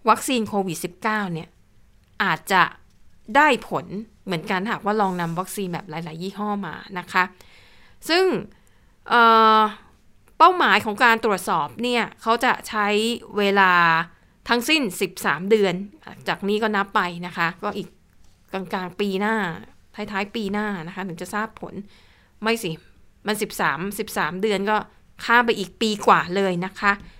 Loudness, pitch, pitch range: -21 LUFS, 205 Hz, 185-220 Hz